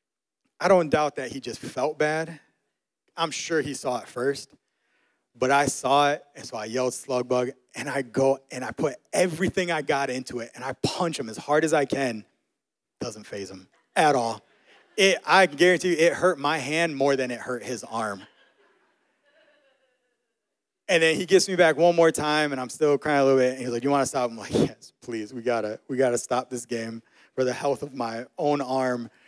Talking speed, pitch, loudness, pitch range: 215 wpm, 140 Hz, -24 LUFS, 125-165 Hz